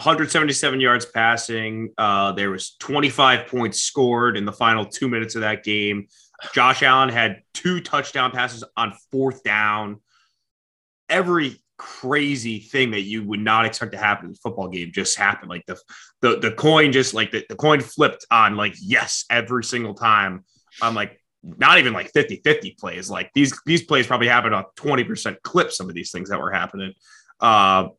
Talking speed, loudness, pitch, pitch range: 180 wpm, -19 LUFS, 115 Hz, 105-130 Hz